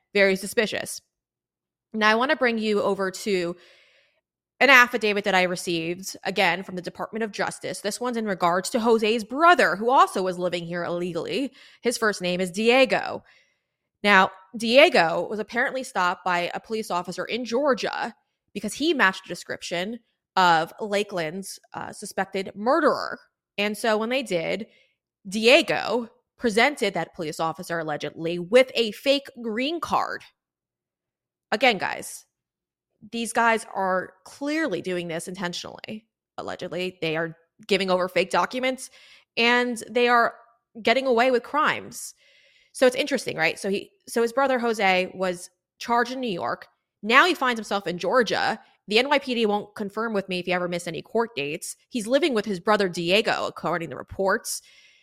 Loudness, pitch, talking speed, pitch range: -23 LUFS, 210 Hz, 155 wpm, 180-240 Hz